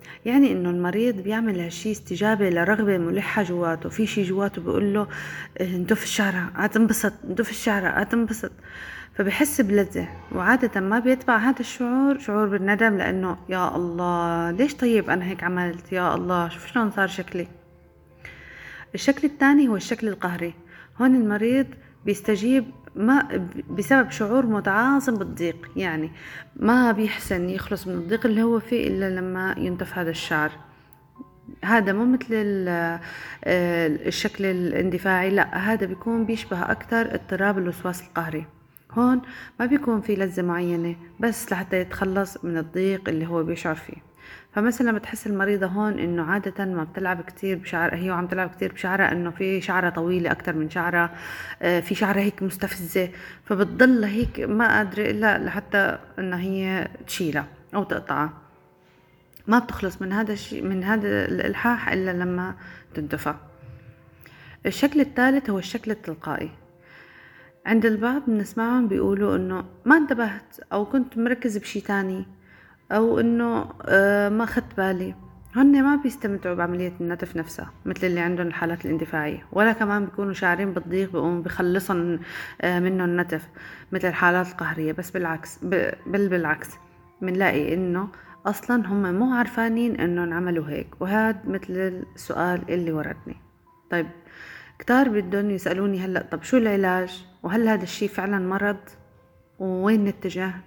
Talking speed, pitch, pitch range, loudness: 135 wpm, 190 Hz, 175-220 Hz, -24 LUFS